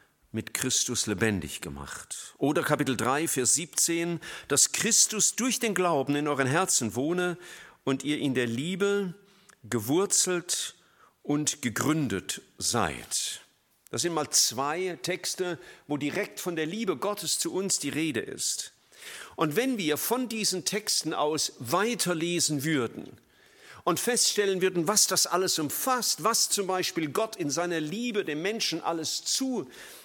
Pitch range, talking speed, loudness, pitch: 145-200 Hz, 140 wpm, -27 LUFS, 170 Hz